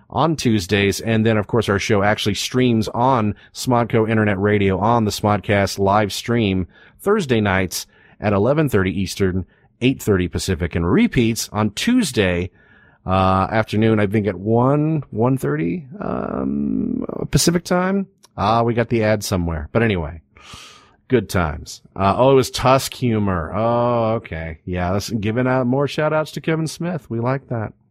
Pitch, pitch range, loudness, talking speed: 110 Hz, 100-130 Hz, -19 LUFS, 150 wpm